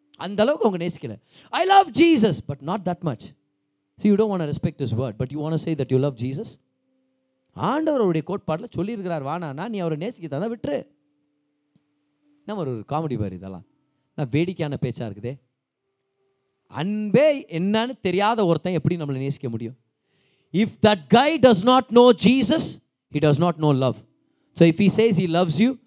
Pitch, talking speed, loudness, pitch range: 165 Hz, 165 wpm, -21 LUFS, 140-220 Hz